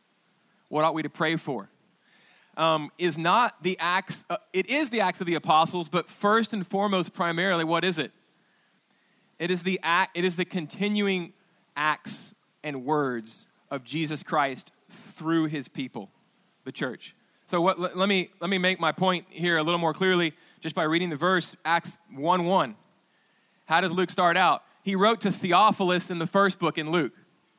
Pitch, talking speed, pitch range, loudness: 180 Hz, 180 wpm, 160-190 Hz, -26 LUFS